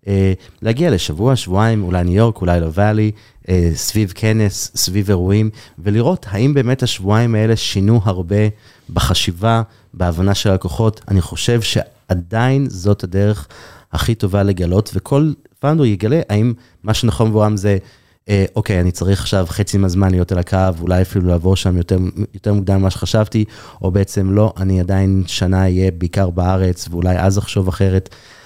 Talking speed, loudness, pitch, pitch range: 155 wpm, -16 LUFS, 100 Hz, 95-110 Hz